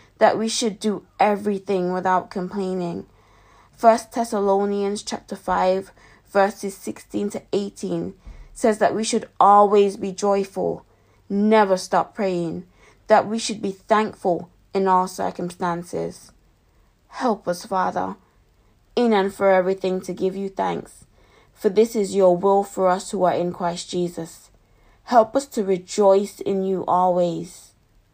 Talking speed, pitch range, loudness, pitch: 135 wpm, 175-205 Hz, -21 LUFS, 190 Hz